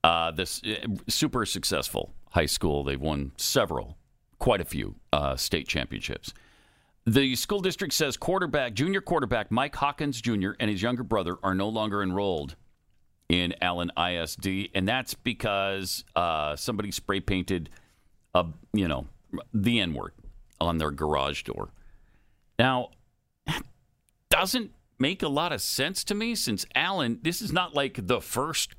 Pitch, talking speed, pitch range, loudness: 100 Hz, 145 wpm, 85-135 Hz, -28 LUFS